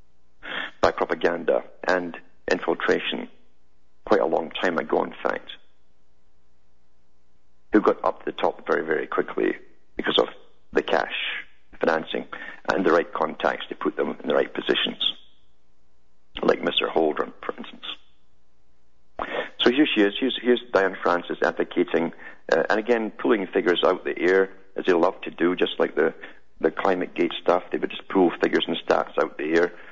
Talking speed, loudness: 160 wpm, -24 LUFS